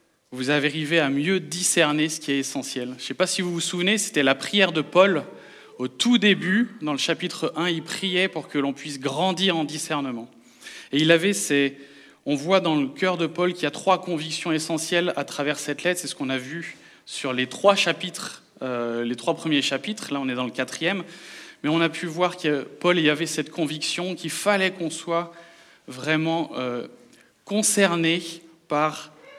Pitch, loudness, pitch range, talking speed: 160 Hz, -23 LUFS, 145-180 Hz, 205 wpm